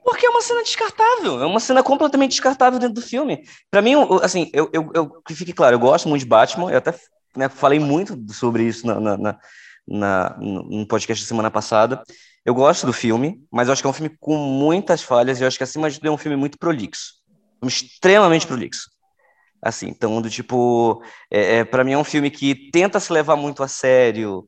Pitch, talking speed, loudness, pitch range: 145 Hz, 215 wpm, -18 LUFS, 120-180 Hz